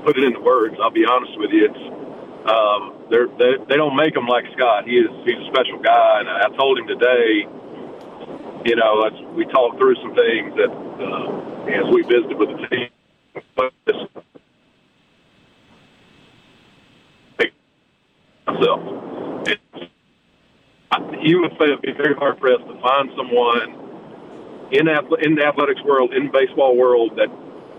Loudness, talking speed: -18 LUFS, 140 wpm